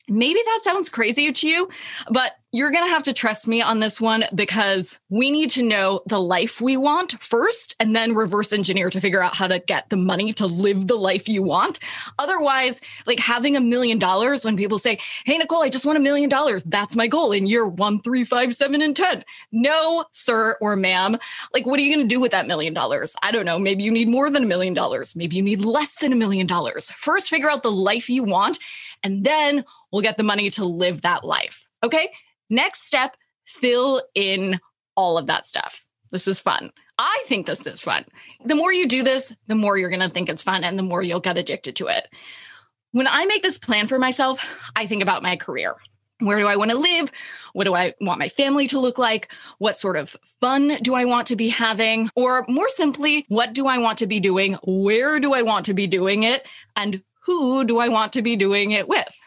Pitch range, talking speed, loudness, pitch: 200-275 Hz, 230 wpm, -20 LUFS, 230 Hz